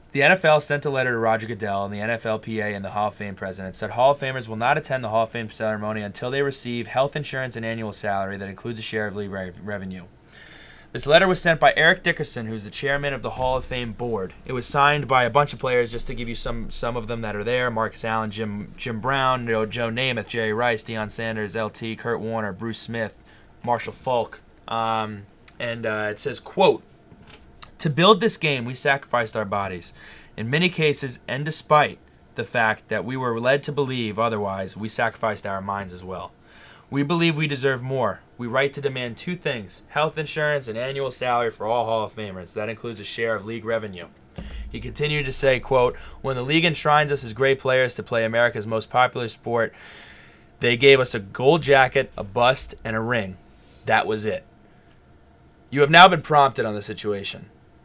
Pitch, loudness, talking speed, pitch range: 120 Hz, -23 LUFS, 210 wpm, 110-135 Hz